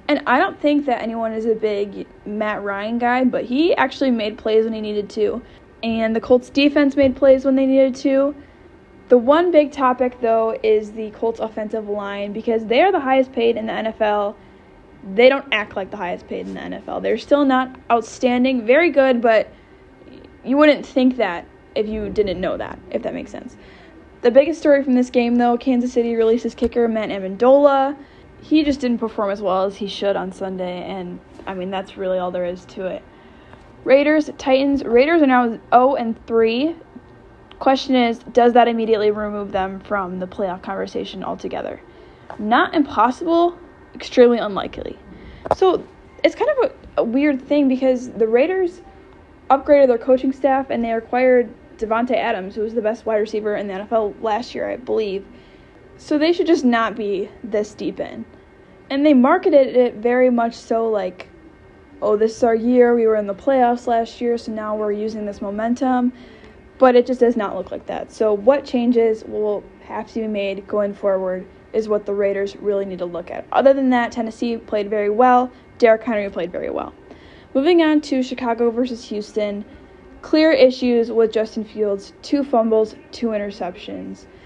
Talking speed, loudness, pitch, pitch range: 185 wpm, -18 LUFS, 230 Hz, 210-265 Hz